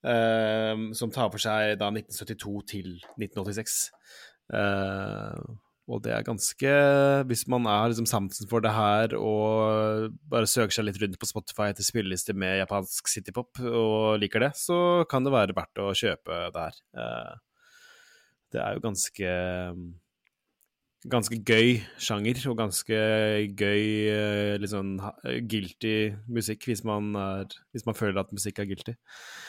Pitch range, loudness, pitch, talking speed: 105-115 Hz, -27 LUFS, 110 Hz, 150 wpm